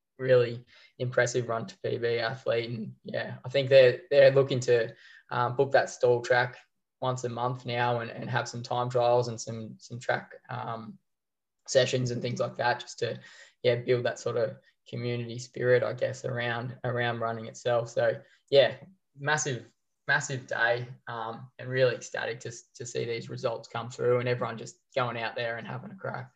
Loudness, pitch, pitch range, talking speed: -29 LUFS, 120 Hz, 120-125 Hz, 185 wpm